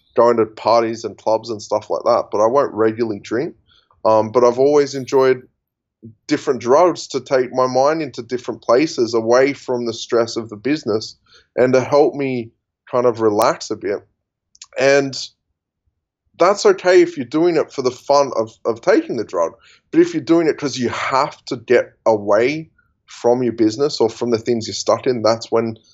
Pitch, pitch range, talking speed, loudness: 125 Hz, 115-140 Hz, 190 wpm, -17 LUFS